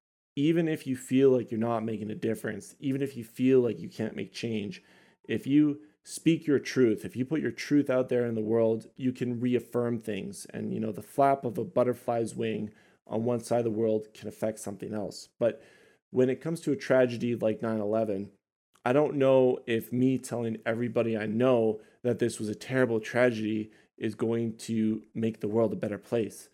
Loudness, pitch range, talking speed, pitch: -29 LUFS, 110-130 Hz, 205 wpm, 115 Hz